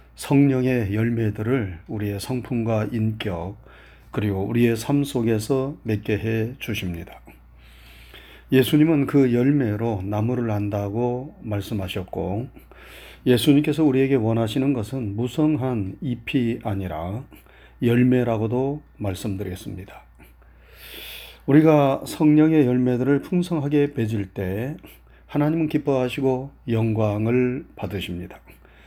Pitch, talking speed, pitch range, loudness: 115 Hz, 250 characters per minute, 100-135 Hz, -22 LUFS